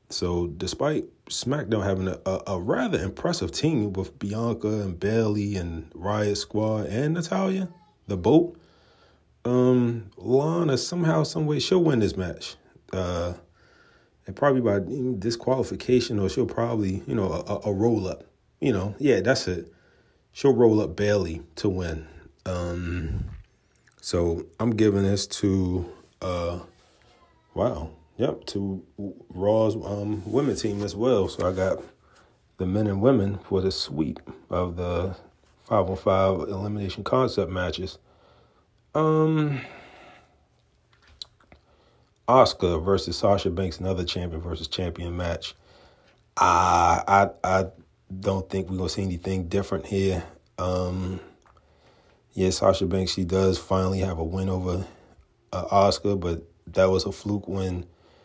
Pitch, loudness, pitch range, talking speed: 95 Hz, -25 LUFS, 90-110 Hz, 130 wpm